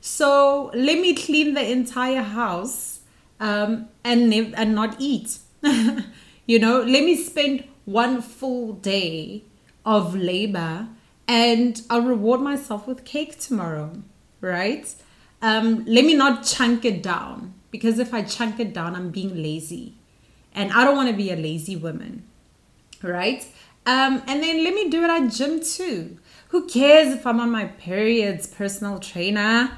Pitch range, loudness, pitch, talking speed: 205-270 Hz, -21 LUFS, 235 Hz, 155 wpm